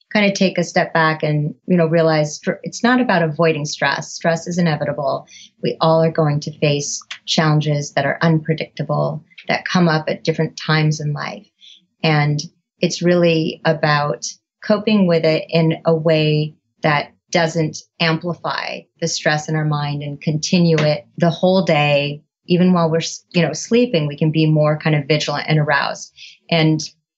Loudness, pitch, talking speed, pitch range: -18 LUFS, 160 Hz, 170 wpm, 150-170 Hz